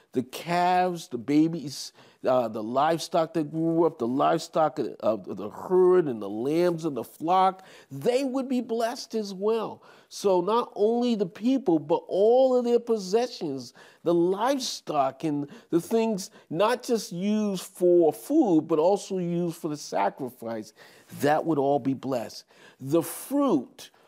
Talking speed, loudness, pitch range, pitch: 150 wpm, -26 LUFS, 155-230 Hz, 180 Hz